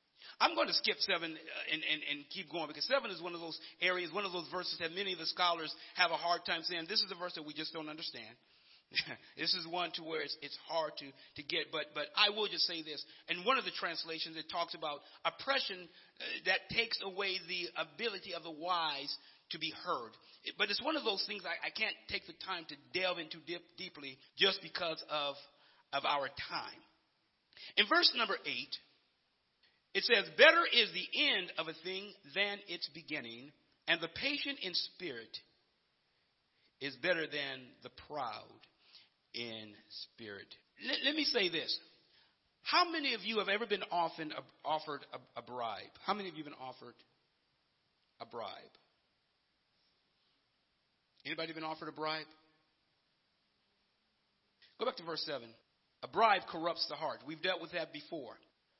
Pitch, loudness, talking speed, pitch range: 170 Hz, -36 LUFS, 180 wpm, 155-190 Hz